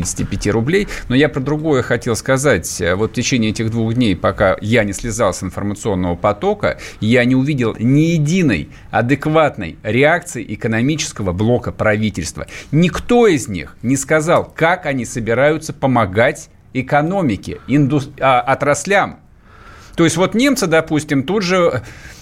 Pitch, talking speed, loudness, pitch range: 130 Hz, 135 wpm, -16 LUFS, 110-155 Hz